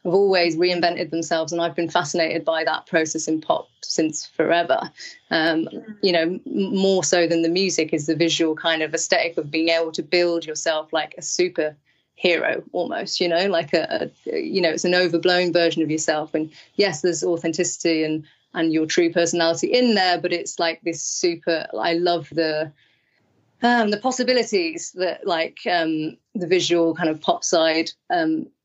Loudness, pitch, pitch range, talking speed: -21 LUFS, 170 Hz, 160-180 Hz, 180 wpm